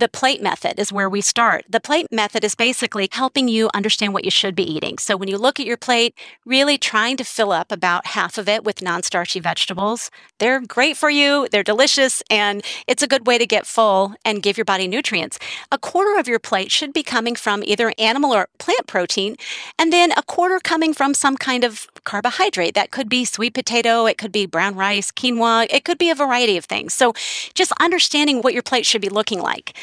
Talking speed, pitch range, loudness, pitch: 225 wpm, 205-270 Hz, -18 LUFS, 230 Hz